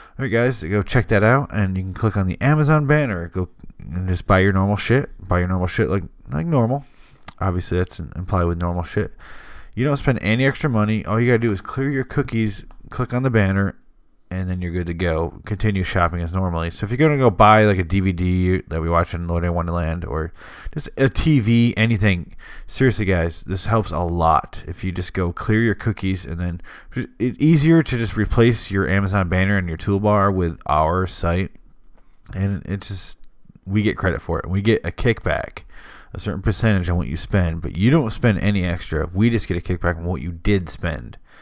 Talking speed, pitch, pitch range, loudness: 215 wpm, 95 Hz, 90-115 Hz, -20 LUFS